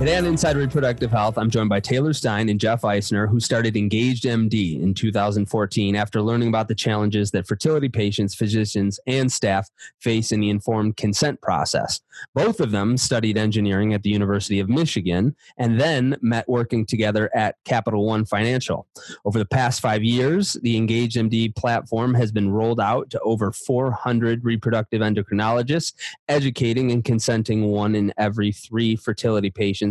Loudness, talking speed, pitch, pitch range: -21 LUFS, 165 wpm, 110 Hz, 105-120 Hz